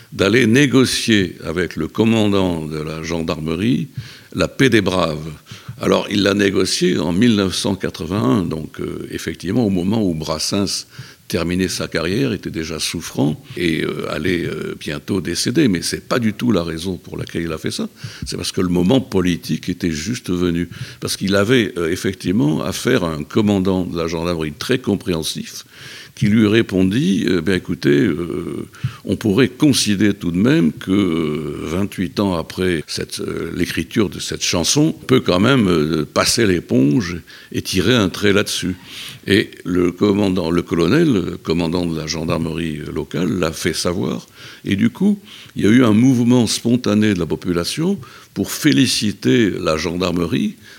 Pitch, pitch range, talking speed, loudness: 95 Hz, 85-115 Hz, 165 wpm, -18 LUFS